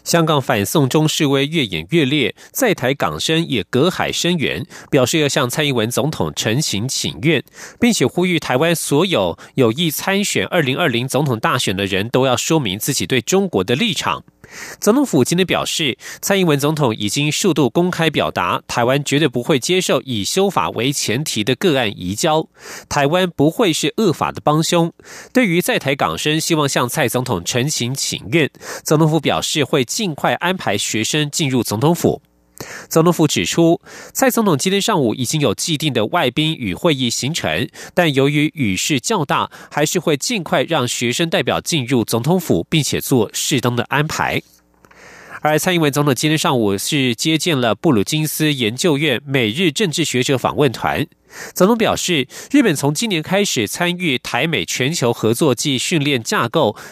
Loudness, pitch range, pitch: -17 LUFS, 125-170 Hz, 150 Hz